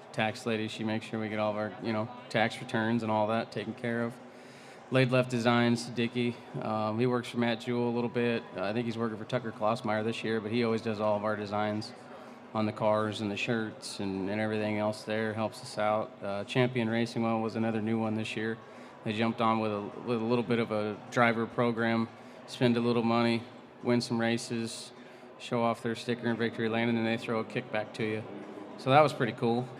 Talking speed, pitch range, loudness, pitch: 230 wpm, 110-120 Hz, -31 LUFS, 115 Hz